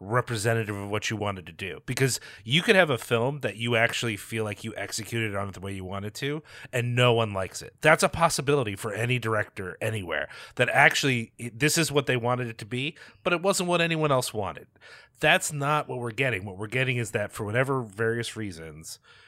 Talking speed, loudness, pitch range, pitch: 220 wpm, -26 LUFS, 105-135 Hz, 120 Hz